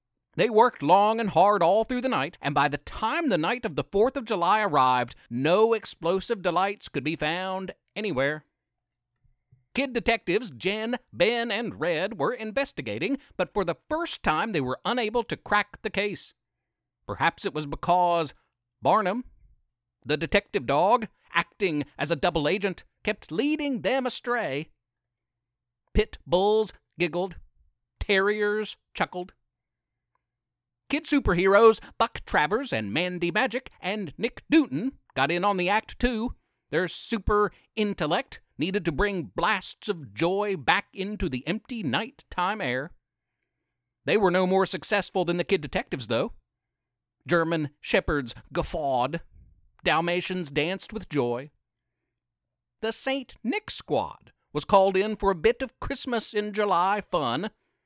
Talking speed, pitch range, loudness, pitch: 140 wpm, 150-220 Hz, -26 LUFS, 190 Hz